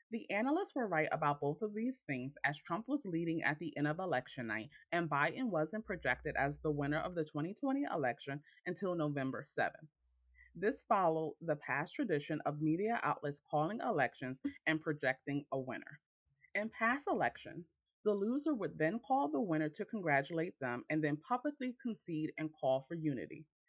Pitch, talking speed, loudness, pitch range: 155 Hz, 170 wpm, -38 LUFS, 145-215 Hz